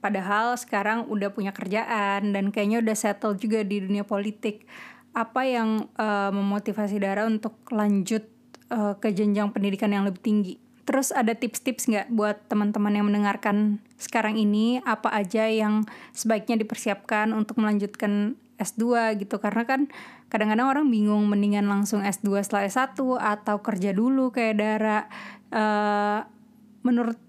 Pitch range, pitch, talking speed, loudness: 205-230 Hz, 215 Hz, 140 wpm, -25 LUFS